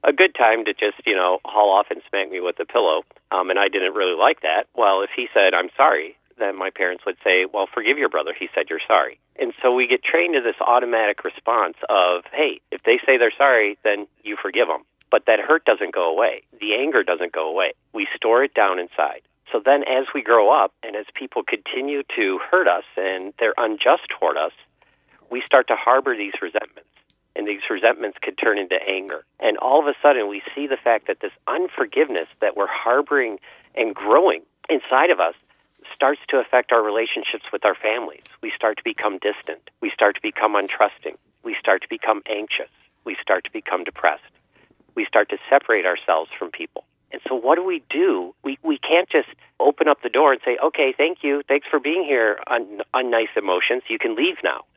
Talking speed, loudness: 215 wpm, -20 LUFS